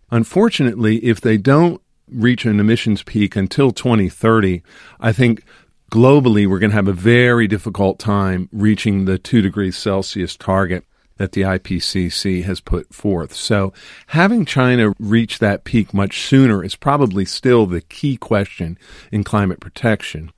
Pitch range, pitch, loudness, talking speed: 95-115 Hz, 105 Hz, -16 LUFS, 145 wpm